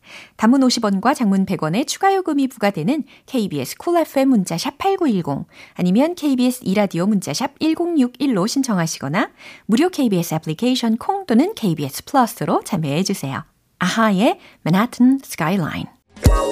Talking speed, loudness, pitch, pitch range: 325 characters per minute, -19 LUFS, 240 Hz, 185-280 Hz